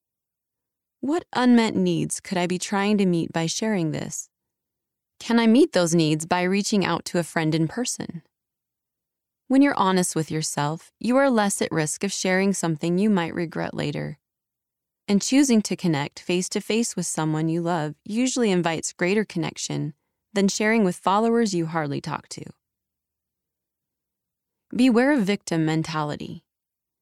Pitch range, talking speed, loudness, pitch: 165-220 Hz, 155 wpm, -23 LUFS, 185 Hz